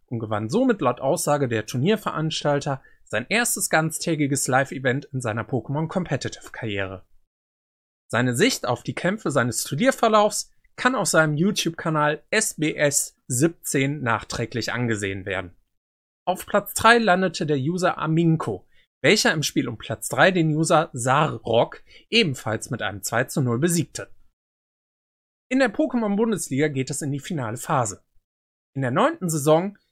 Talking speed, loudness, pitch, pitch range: 135 wpm, -23 LUFS, 150 Hz, 120-180 Hz